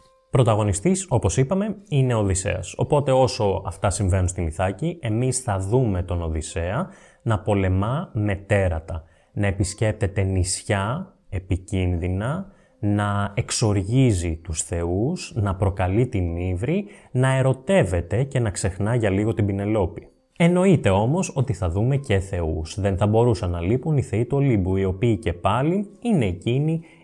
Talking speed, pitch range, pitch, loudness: 140 wpm, 95-135 Hz, 105 Hz, -23 LUFS